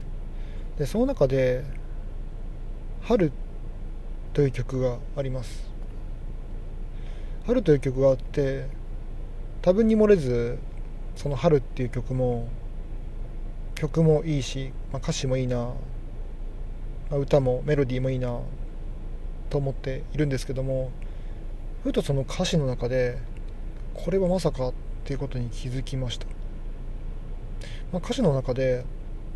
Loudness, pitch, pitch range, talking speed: -26 LUFS, 130 Hz, 115-140 Hz, 215 characters per minute